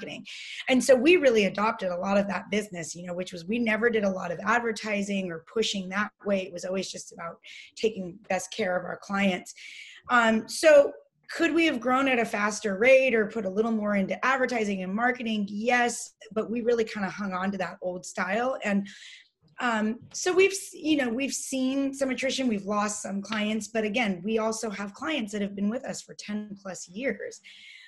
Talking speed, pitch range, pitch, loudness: 210 wpm, 195-245 Hz, 215 Hz, -27 LUFS